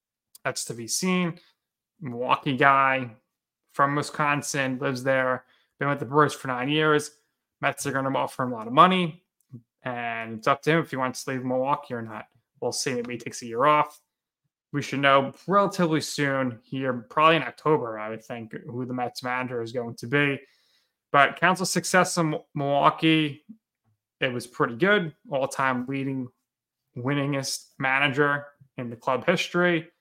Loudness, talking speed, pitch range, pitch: -25 LUFS, 170 wpm, 125-155 Hz, 140 Hz